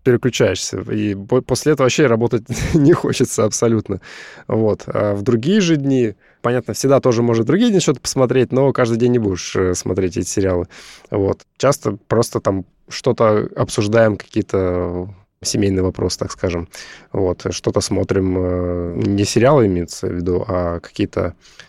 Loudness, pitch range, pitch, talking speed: -17 LUFS, 95-125 Hz, 105 Hz, 145 wpm